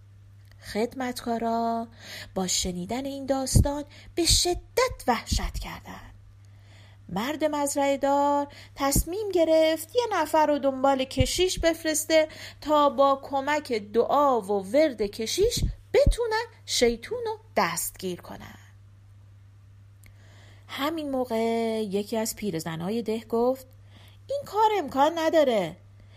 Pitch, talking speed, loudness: 240 Hz, 100 wpm, -26 LUFS